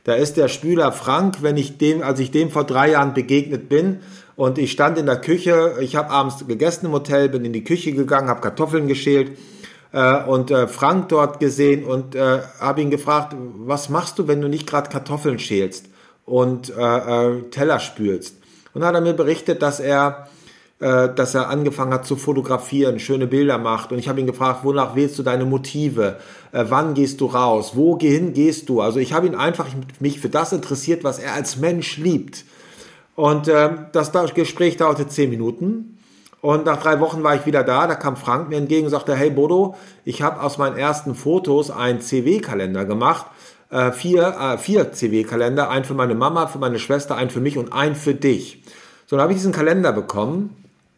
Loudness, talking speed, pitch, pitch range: -19 LUFS, 195 wpm, 140 Hz, 130-155 Hz